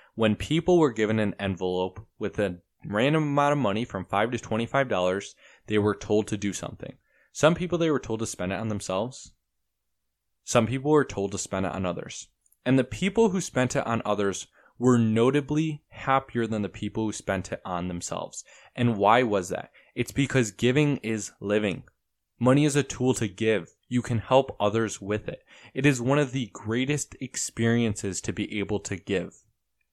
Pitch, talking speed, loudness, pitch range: 115 Hz, 190 wpm, -26 LUFS, 100-130 Hz